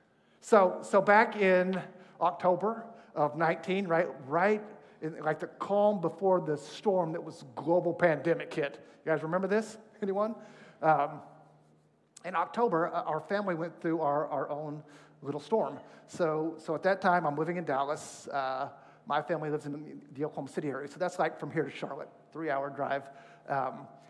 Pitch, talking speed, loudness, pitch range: 165 Hz, 165 wpm, -31 LUFS, 150-190 Hz